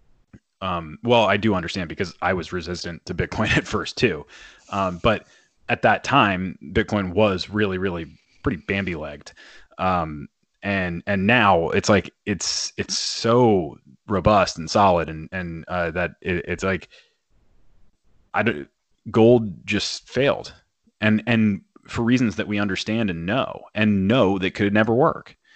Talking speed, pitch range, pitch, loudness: 155 wpm, 85-105 Hz, 95 Hz, -22 LUFS